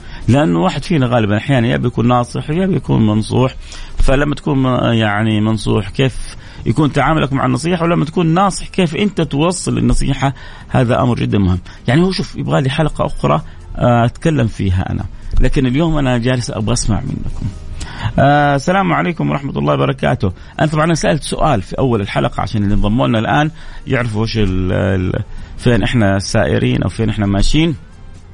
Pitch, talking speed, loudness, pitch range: 120 Hz, 155 wpm, -15 LUFS, 100-145 Hz